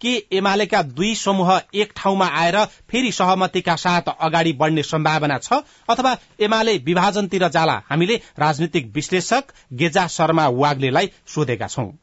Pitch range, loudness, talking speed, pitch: 155-200 Hz, -19 LUFS, 130 wpm, 180 Hz